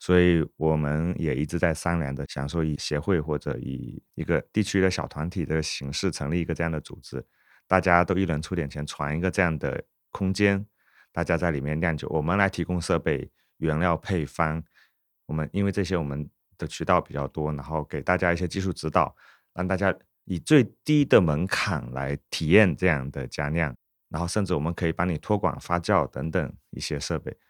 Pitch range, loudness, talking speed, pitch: 75-90 Hz, -26 LUFS, 295 characters per minute, 85 Hz